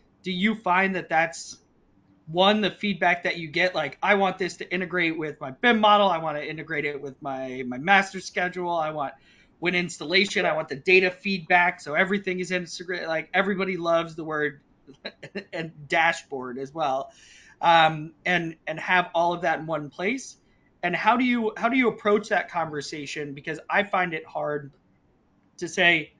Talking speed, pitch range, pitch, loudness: 185 wpm, 155-185 Hz, 170 Hz, -24 LUFS